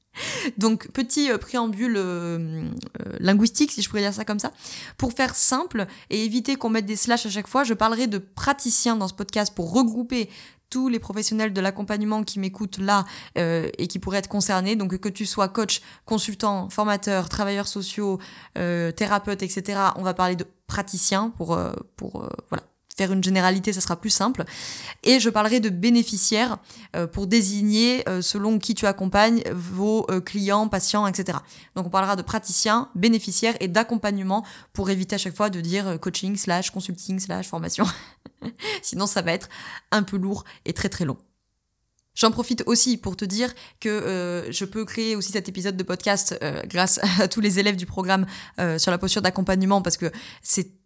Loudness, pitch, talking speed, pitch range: -22 LUFS, 205 Hz, 175 wpm, 190-220 Hz